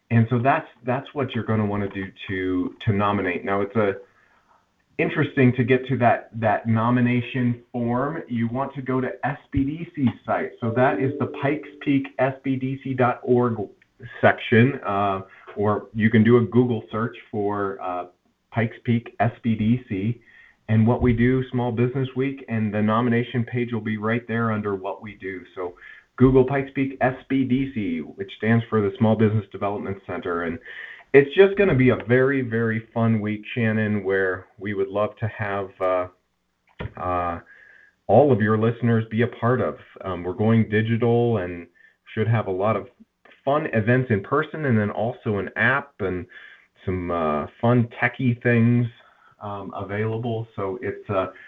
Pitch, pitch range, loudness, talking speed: 115 Hz, 105-125 Hz, -23 LUFS, 165 wpm